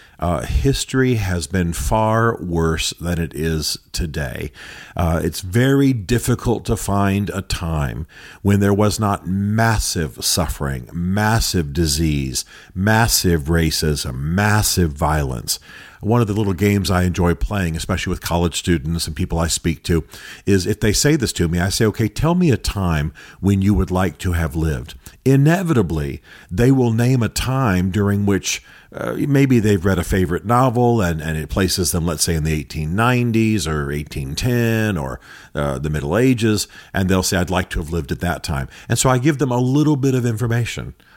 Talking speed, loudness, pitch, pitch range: 175 wpm, -19 LUFS, 95 Hz, 80-110 Hz